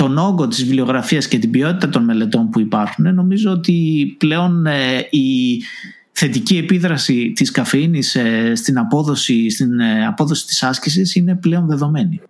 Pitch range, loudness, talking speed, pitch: 130-180 Hz, -15 LUFS, 135 wpm, 155 Hz